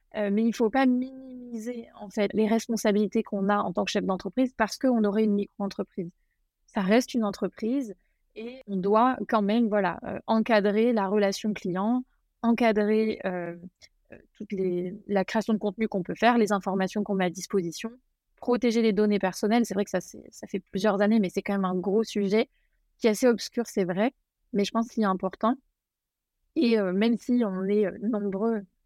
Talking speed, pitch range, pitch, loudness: 200 wpm, 200-230 Hz, 215 Hz, -26 LUFS